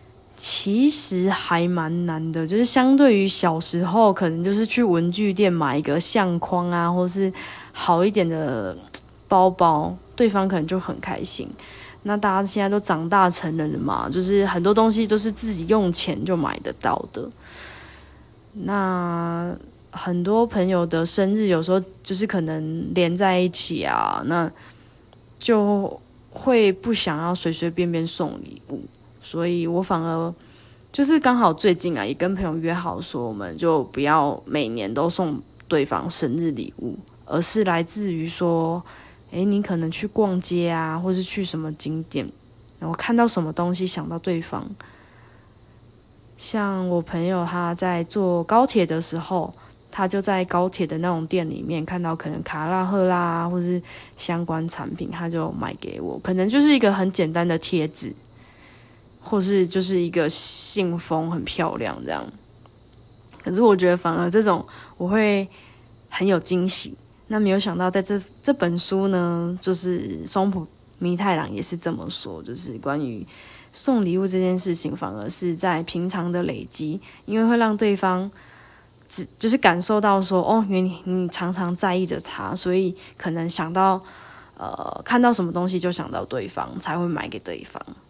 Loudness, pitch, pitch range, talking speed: -22 LUFS, 180 Hz, 165-195 Hz, 235 characters per minute